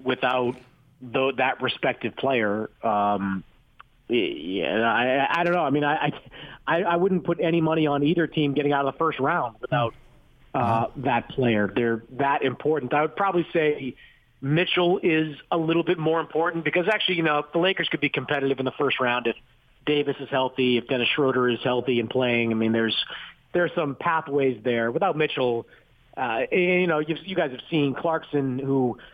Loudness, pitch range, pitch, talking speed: -24 LUFS, 125-165 Hz, 140 Hz, 185 wpm